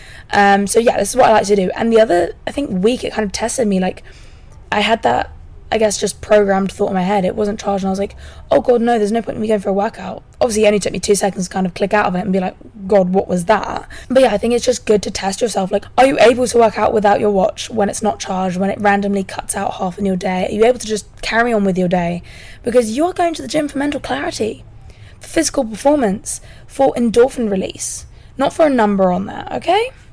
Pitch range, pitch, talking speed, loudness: 195-235 Hz, 210 Hz, 275 wpm, -16 LUFS